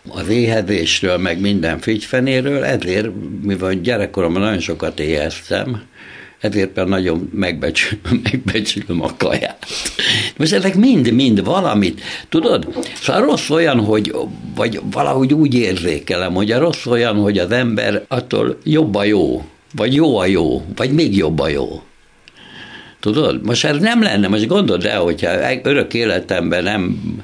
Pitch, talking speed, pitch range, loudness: 105 Hz, 140 wpm, 95-120 Hz, -16 LUFS